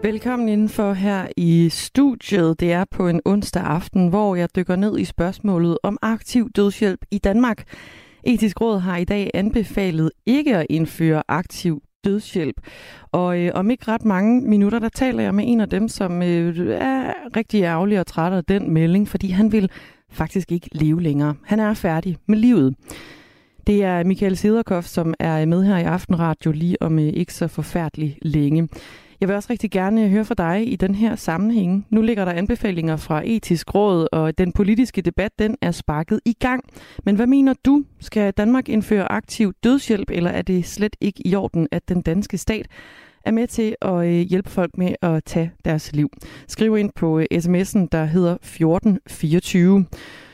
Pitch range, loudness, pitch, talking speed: 170-215 Hz, -20 LUFS, 190 Hz, 180 wpm